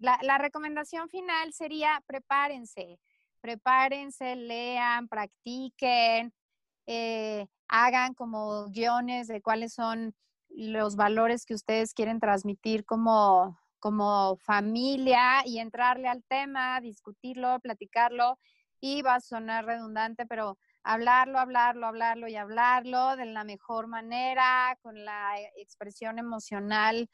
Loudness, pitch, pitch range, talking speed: -28 LUFS, 235 Hz, 220-255 Hz, 110 wpm